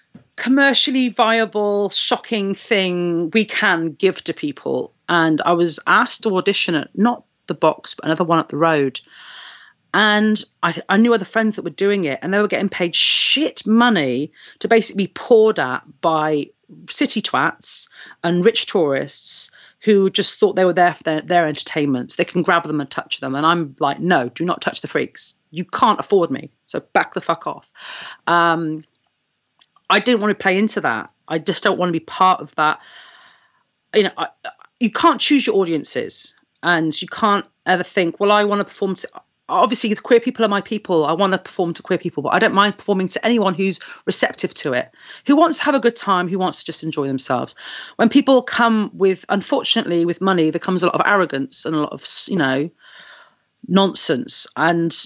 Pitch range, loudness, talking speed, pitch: 170-225 Hz, -17 LUFS, 200 wpm, 195 Hz